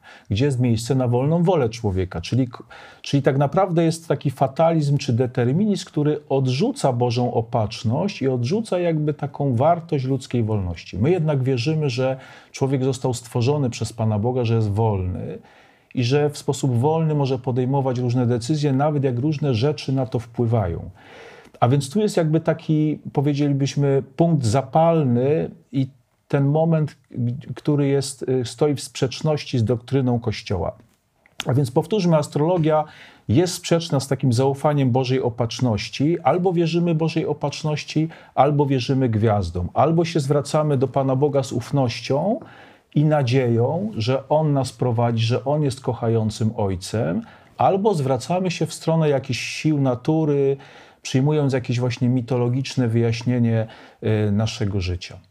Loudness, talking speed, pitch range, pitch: -21 LUFS, 140 wpm, 120-150 Hz, 135 Hz